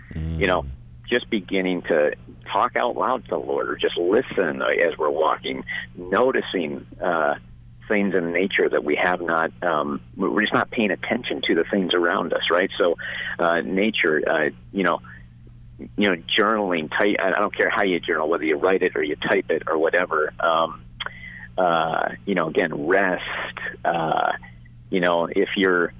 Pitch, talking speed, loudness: 85 Hz, 175 wpm, -22 LUFS